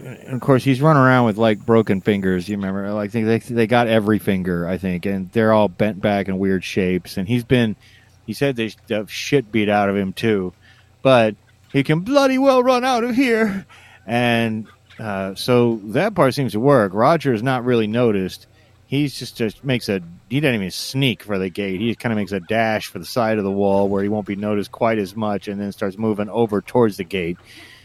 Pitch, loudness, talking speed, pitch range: 110 Hz, -19 LUFS, 220 wpm, 100-125 Hz